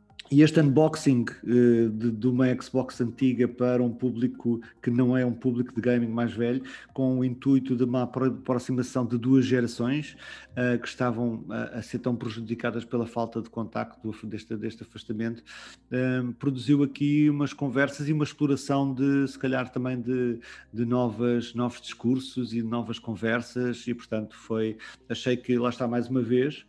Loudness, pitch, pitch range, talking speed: -27 LUFS, 125 Hz, 115-130 Hz, 165 wpm